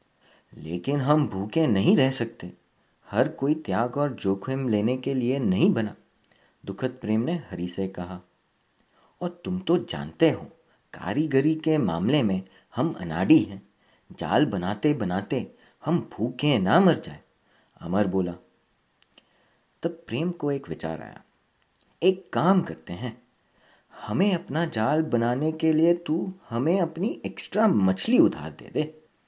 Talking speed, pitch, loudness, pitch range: 140 wpm, 135 Hz, -26 LUFS, 100-160 Hz